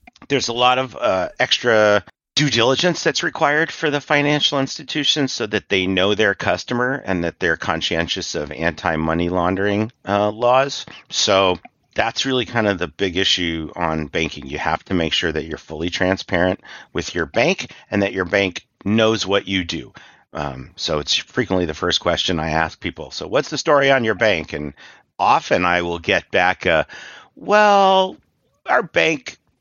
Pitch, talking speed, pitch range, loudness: 100 Hz, 175 wpm, 85-130 Hz, -19 LUFS